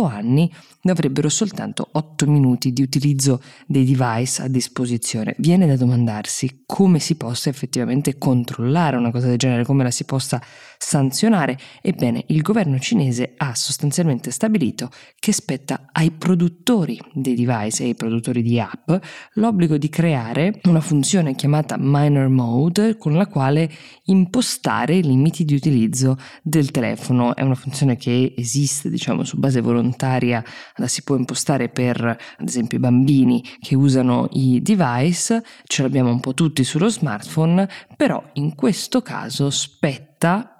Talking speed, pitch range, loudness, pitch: 145 wpm, 125-165 Hz, -19 LUFS, 140 Hz